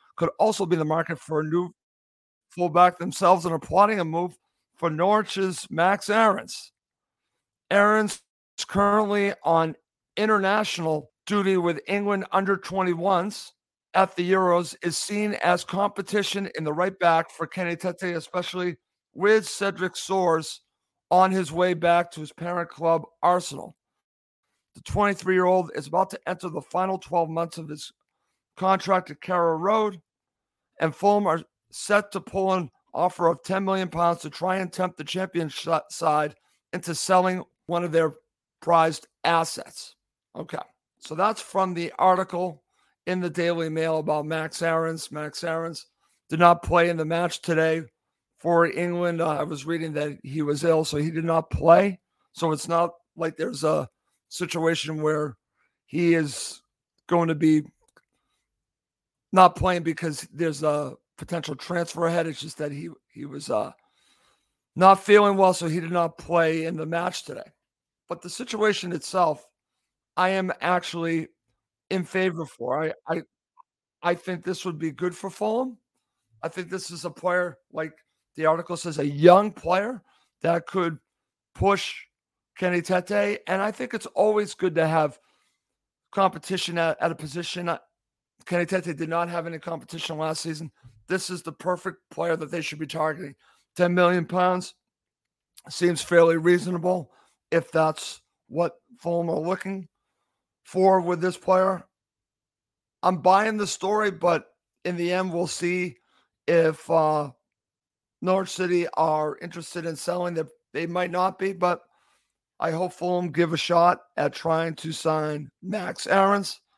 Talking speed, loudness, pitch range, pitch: 150 wpm, -24 LUFS, 160-185 Hz, 175 Hz